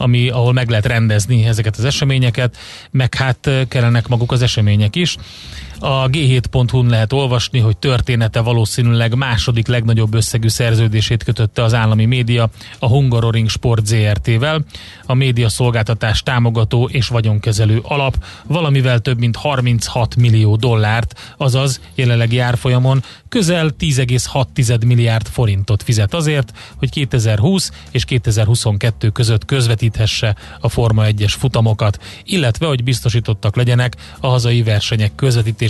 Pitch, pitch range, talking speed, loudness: 120 Hz, 110-130 Hz, 125 wpm, -15 LUFS